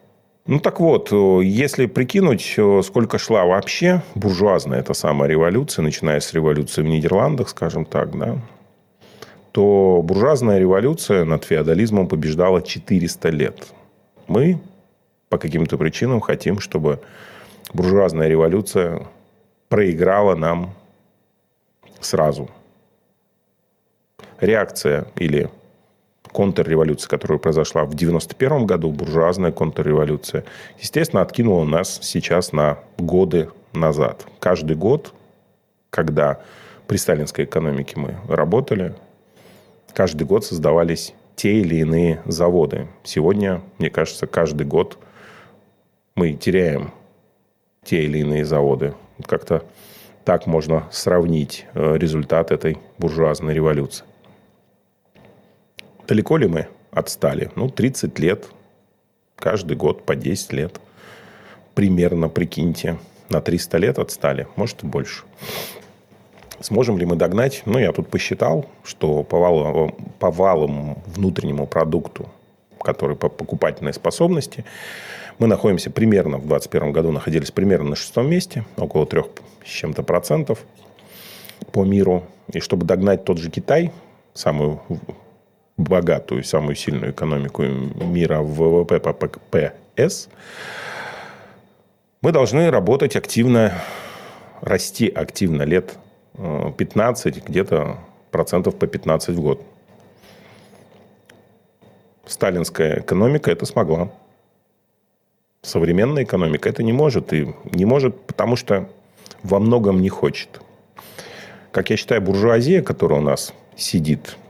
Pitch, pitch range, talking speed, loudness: 85 Hz, 75-100 Hz, 105 wpm, -19 LUFS